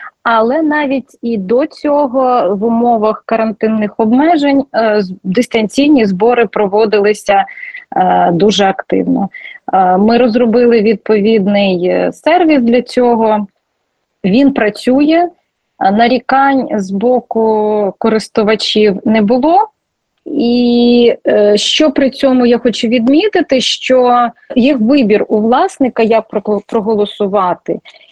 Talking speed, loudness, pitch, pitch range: 90 wpm, -11 LUFS, 235 Hz, 215-270 Hz